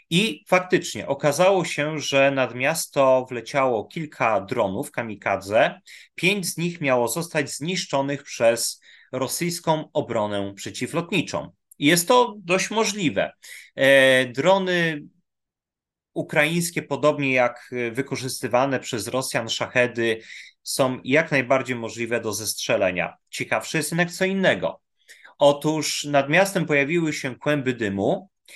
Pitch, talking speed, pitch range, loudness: 140 Hz, 110 wpm, 125-165 Hz, -22 LUFS